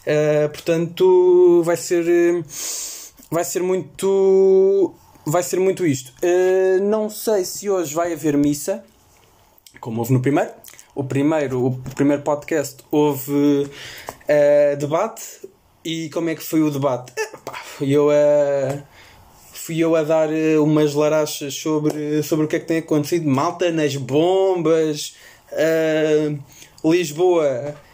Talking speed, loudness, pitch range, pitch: 135 wpm, -19 LUFS, 145-175 Hz, 155 Hz